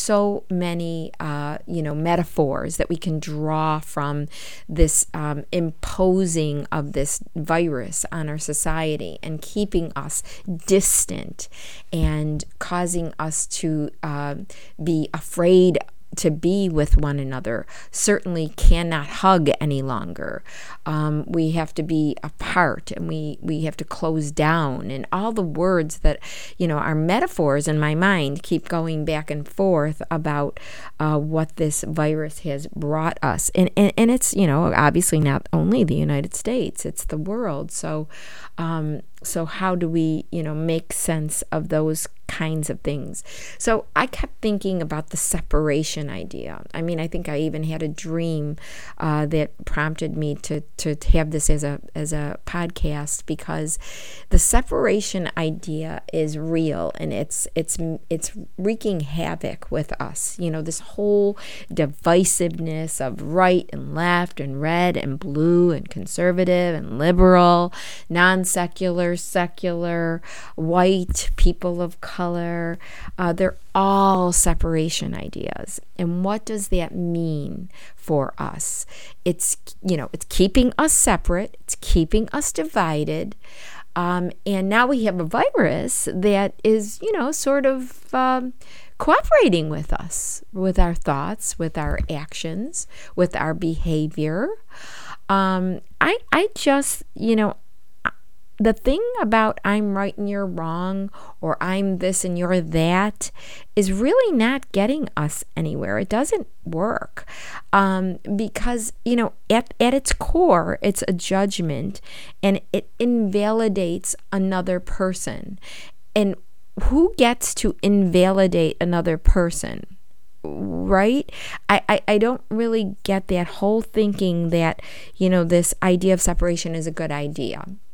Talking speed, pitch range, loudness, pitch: 140 wpm, 155-195 Hz, -22 LUFS, 175 Hz